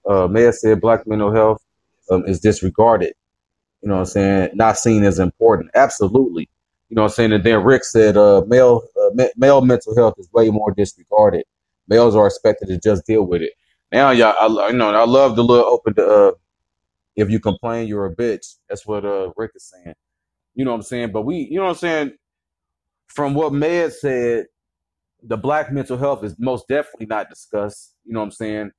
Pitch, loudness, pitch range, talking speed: 110 Hz, -16 LUFS, 100-125 Hz, 210 wpm